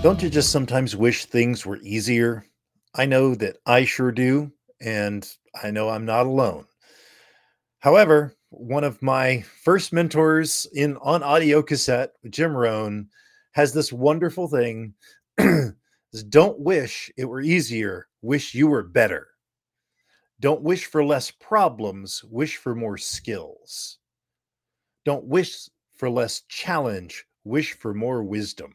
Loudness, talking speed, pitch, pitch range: -22 LUFS, 135 wpm, 130 Hz, 115-150 Hz